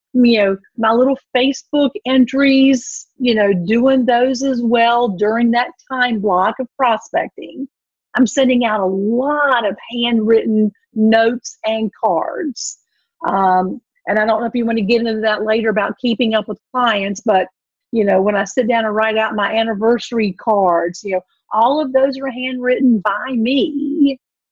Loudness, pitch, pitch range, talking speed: -16 LUFS, 235 Hz, 215-260 Hz, 165 wpm